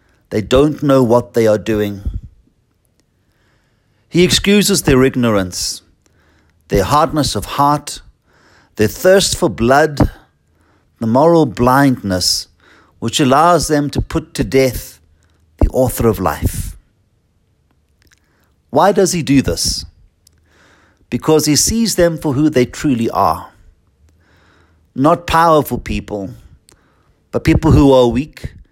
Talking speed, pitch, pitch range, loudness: 115 wpm, 110 Hz, 90-145 Hz, -14 LUFS